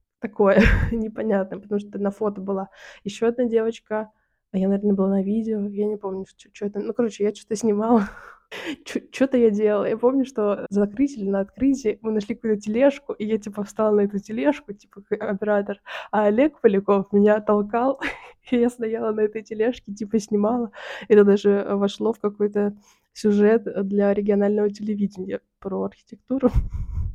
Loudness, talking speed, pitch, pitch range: -23 LUFS, 160 wpm, 210 Hz, 200-225 Hz